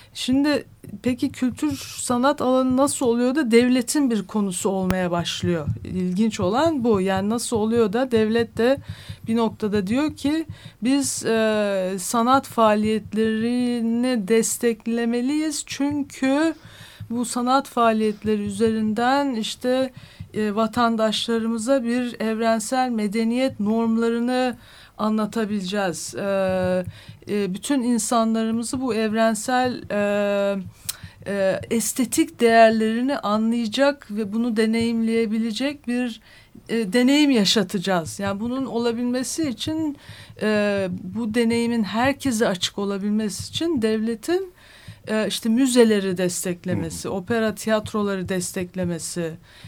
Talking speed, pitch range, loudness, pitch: 95 wpm, 210-250 Hz, -22 LUFS, 225 Hz